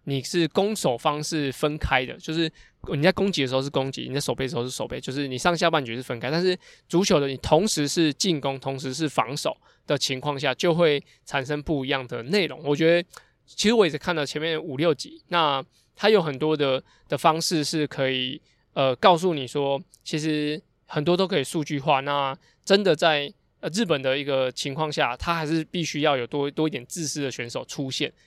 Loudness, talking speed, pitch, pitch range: -24 LUFS, 305 characters per minute, 150 Hz, 135-165 Hz